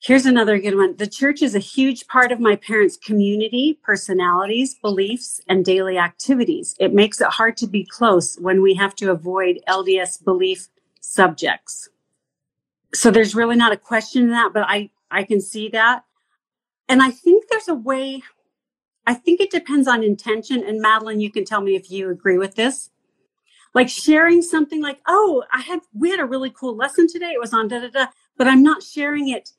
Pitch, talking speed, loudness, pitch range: 235 Hz, 195 wpm, -18 LUFS, 200-270 Hz